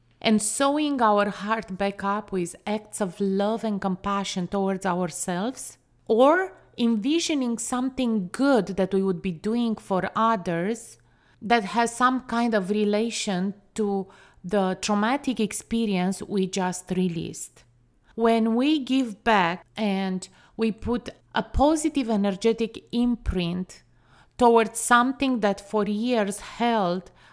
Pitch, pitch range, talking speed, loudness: 210 Hz, 190-235 Hz, 120 wpm, -25 LUFS